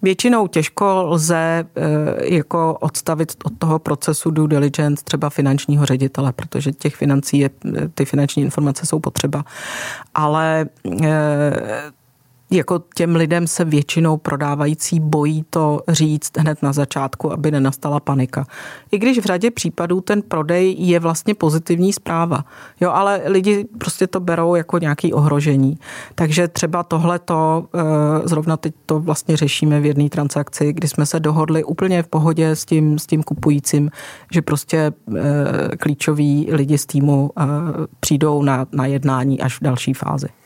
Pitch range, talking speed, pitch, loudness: 145-165 Hz, 145 wpm, 155 Hz, -18 LUFS